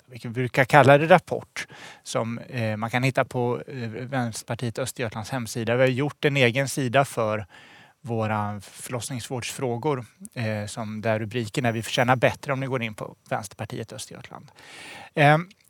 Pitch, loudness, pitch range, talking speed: 125 Hz, -24 LUFS, 115-135 Hz, 150 wpm